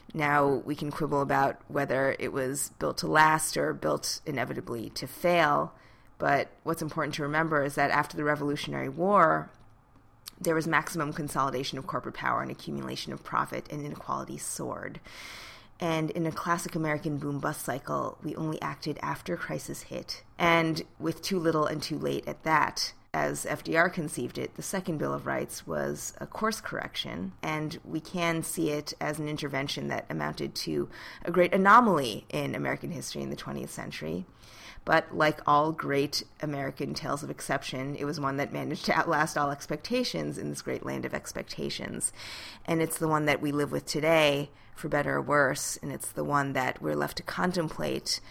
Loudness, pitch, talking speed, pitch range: -29 LUFS, 145 Hz, 180 wpm, 135-160 Hz